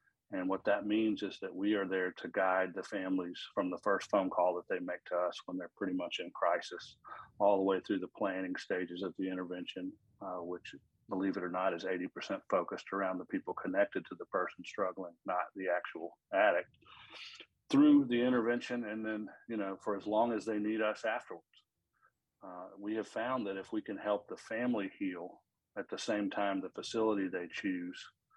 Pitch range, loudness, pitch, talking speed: 95-110 Hz, -36 LUFS, 100 Hz, 200 wpm